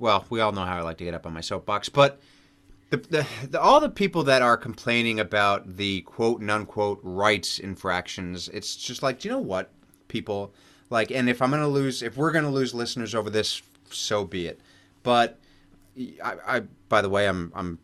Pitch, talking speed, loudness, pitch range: 105 Hz, 210 wpm, -25 LUFS, 95-125 Hz